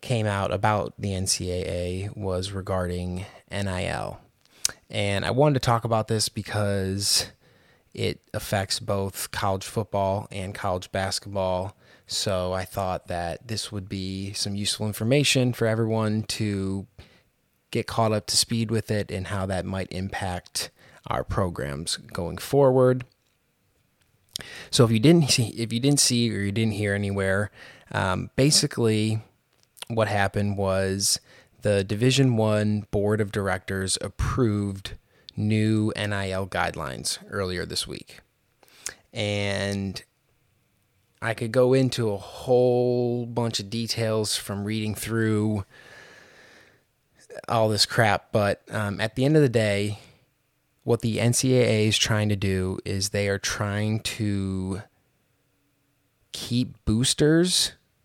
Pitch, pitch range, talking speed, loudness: 105 Hz, 95-115 Hz, 125 wpm, -25 LUFS